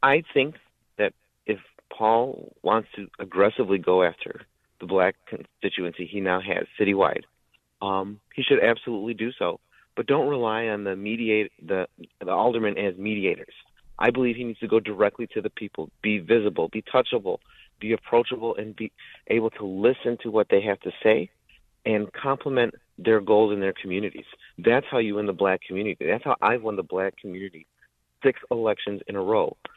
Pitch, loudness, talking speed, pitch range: 105 Hz, -25 LUFS, 175 wpm, 100-115 Hz